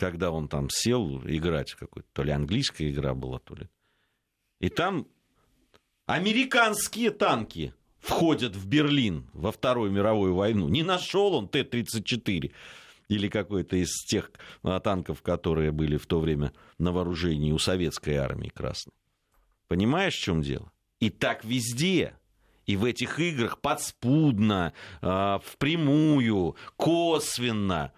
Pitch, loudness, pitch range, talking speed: 100 Hz, -27 LUFS, 80-135 Hz, 125 wpm